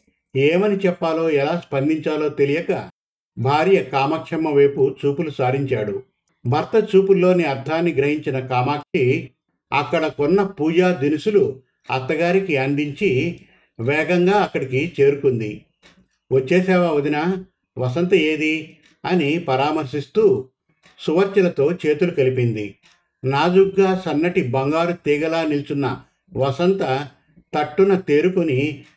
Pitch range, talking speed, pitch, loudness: 140-180 Hz, 85 wpm, 155 Hz, -19 LUFS